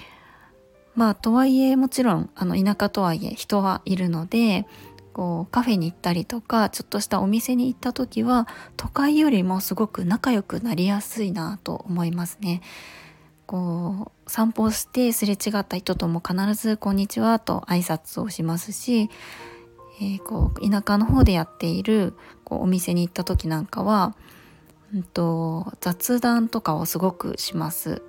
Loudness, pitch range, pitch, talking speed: -23 LUFS, 175-225 Hz, 200 Hz, 320 characters per minute